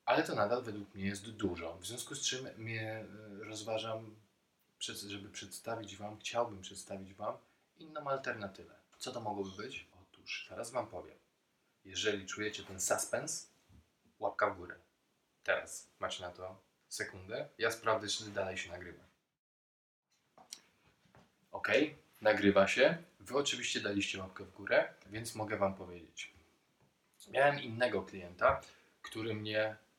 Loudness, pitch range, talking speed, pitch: -37 LUFS, 95-110 Hz, 130 wpm, 105 Hz